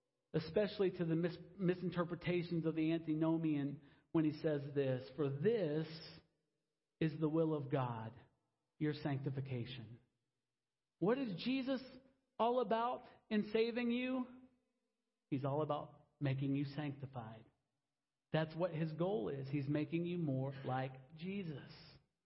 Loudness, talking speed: -40 LUFS, 125 wpm